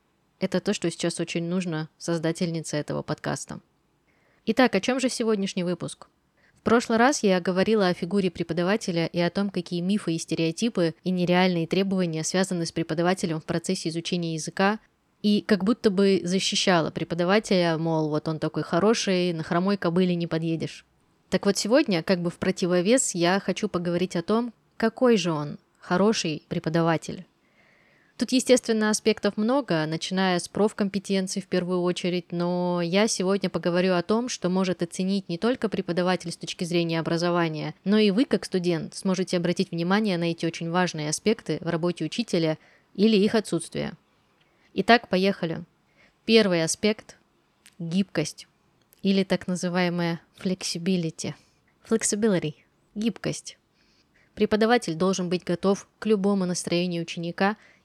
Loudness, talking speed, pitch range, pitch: -25 LUFS, 140 wpm, 170-205 Hz, 185 Hz